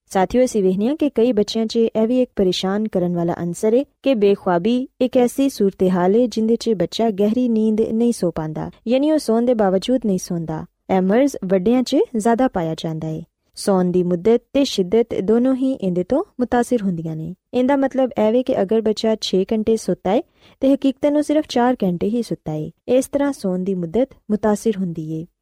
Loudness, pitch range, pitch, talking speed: -19 LUFS, 185-250 Hz, 225 Hz, 190 wpm